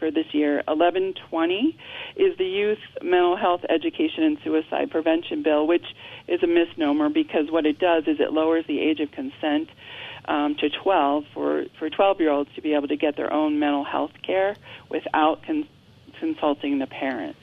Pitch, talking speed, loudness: 165 Hz, 180 wpm, -23 LUFS